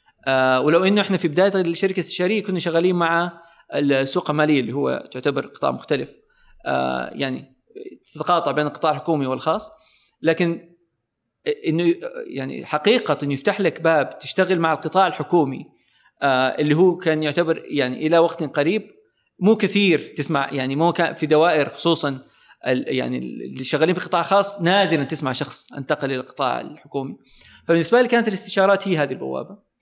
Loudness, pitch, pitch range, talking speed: -21 LUFS, 165 Hz, 145-185 Hz, 150 wpm